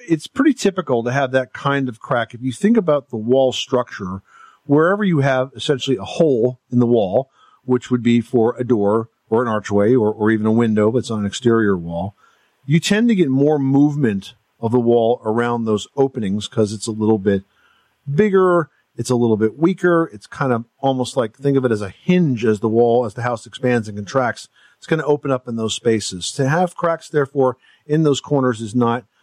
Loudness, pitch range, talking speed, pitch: -18 LUFS, 110-140 Hz, 215 wpm, 125 Hz